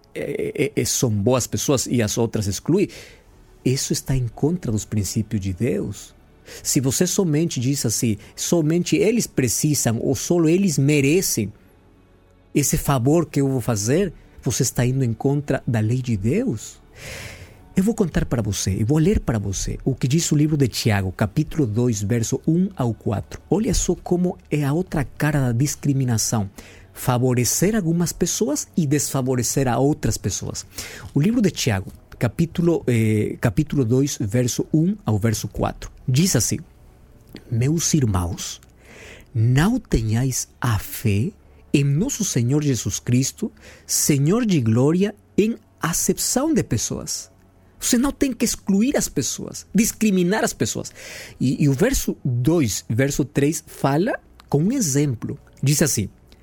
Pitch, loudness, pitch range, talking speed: 135 Hz, -21 LUFS, 110-160 Hz, 150 wpm